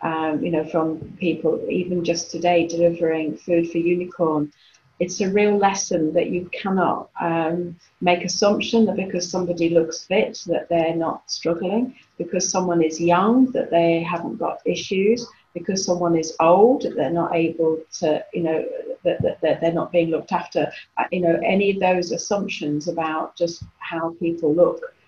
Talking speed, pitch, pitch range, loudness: 165 wpm, 170 Hz, 165-185 Hz, -21 LUFS